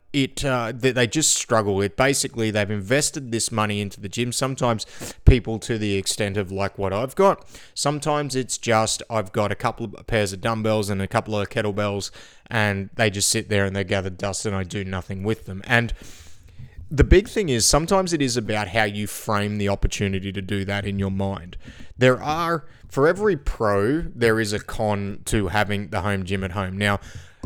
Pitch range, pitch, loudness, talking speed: 100-120 Hz, 105 Hz, -23 LUFS, 205 wpm